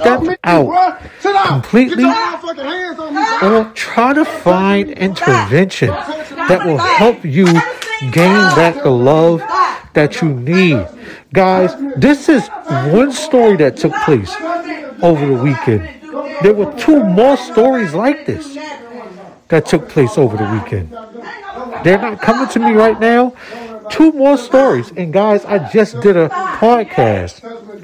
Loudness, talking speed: -12 LUFS, 130 wpm